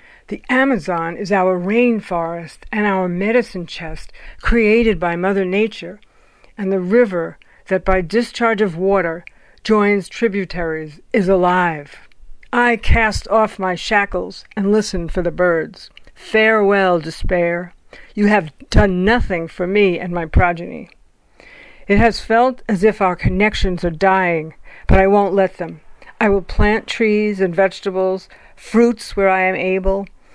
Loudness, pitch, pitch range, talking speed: -17 LUFS, 195 Hz, 180-215 Hz, 140 wpm